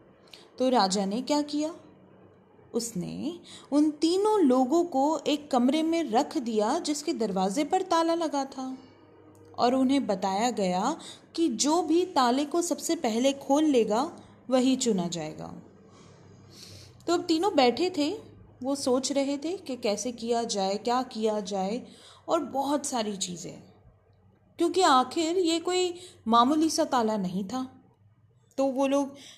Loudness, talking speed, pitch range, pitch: -27 LUFS, 140 wpm, 230-315 Hz, 270 Hz